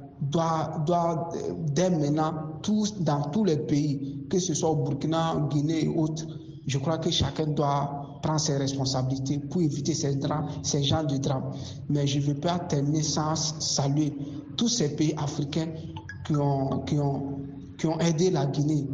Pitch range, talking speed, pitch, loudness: 140-160 Hz, 170 wpm, 150 Hz, -27 LUFS